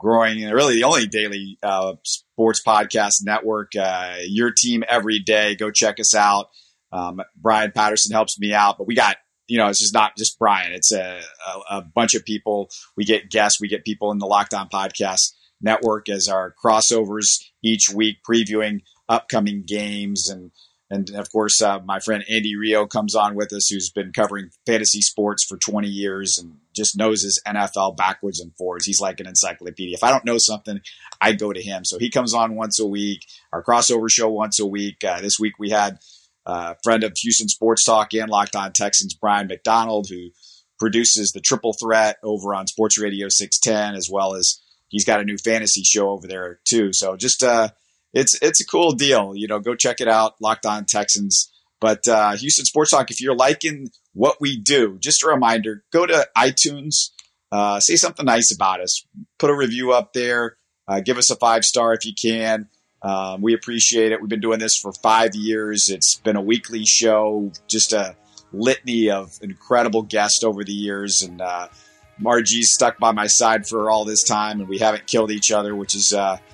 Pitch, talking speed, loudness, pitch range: 105 Hz, 200 wpm, -18 LUFS, 100-110 Hz